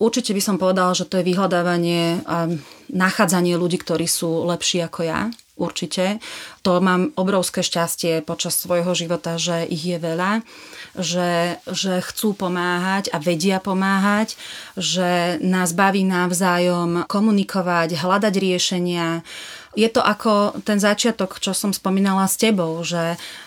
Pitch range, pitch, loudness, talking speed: 175-195 Hz, 180 Hz, -20 LUFS, 135 wpm